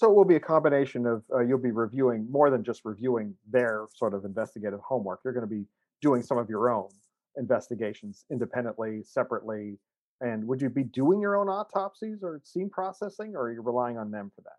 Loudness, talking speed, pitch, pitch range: -29 LUFS, 210 wpm, 120 Hz, 110-150 Hz